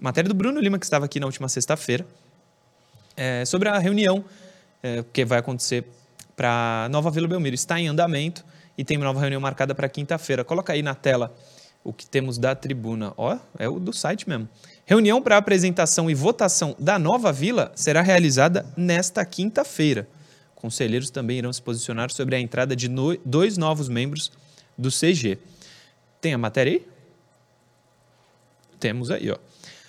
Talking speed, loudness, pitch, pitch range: 160 wpm, -23 LUFS, 150 Hz, 130-180 Hz